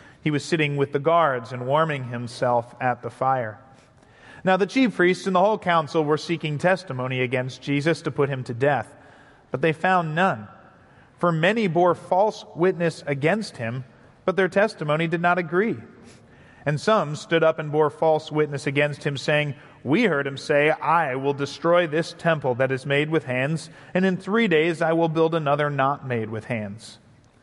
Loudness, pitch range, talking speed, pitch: -23 LUFS, 135-170 Hz, 185 wpm, 150 Hz